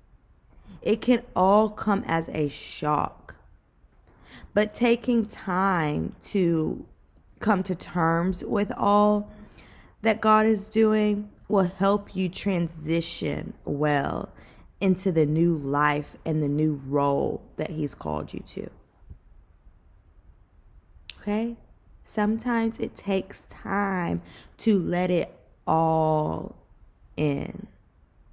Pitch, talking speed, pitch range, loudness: 170 Hz, 100 wpm, 140-205 Hz, -25 LUFS